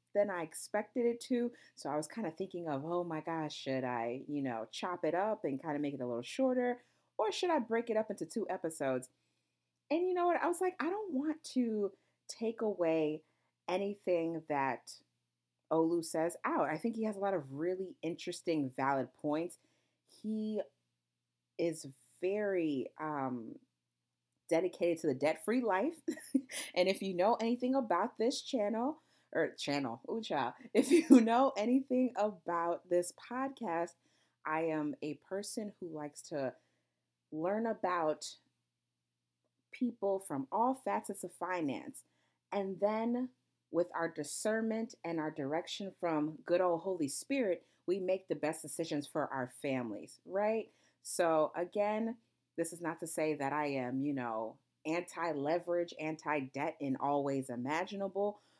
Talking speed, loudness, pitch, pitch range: 155 wpm, -36 LUFS, 170 Hz, 145-220 Hz